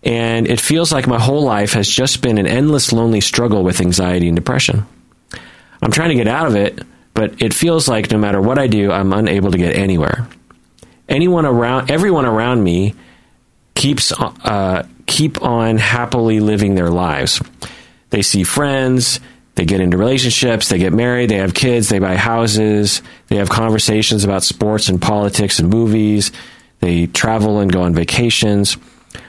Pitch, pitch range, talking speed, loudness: 110 Hz, 100-120 Hz, 170 wpm, -14 LUFS